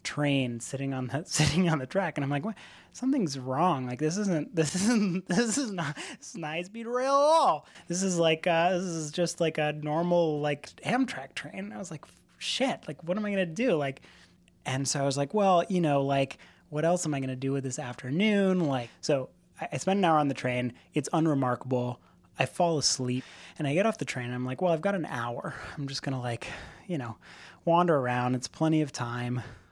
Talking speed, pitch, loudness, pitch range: 230 wpm, 155 Hz, -29 LUFS, 130-180 Hz